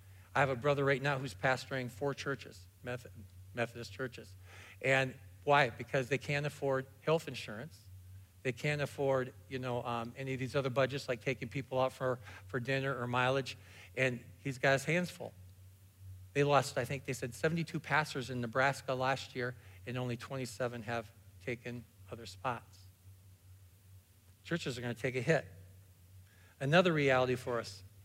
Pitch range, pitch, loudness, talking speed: 95-135 Hz, 125 Hz, -35 LUFS, 165 wpm